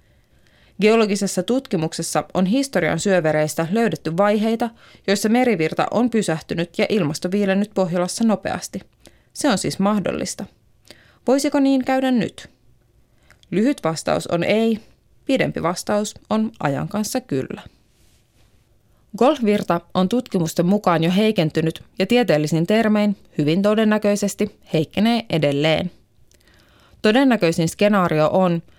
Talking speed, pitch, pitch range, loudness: 105 wpm, 195 Hz, 165-220 Hz, -20 LUFS